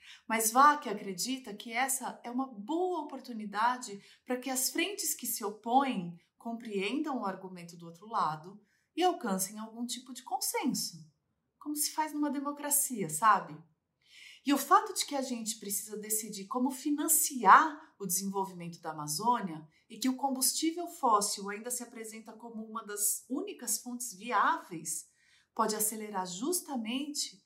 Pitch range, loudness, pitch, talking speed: 200-275 Hz, -31 LUFS, 235 Hz, 150 wpm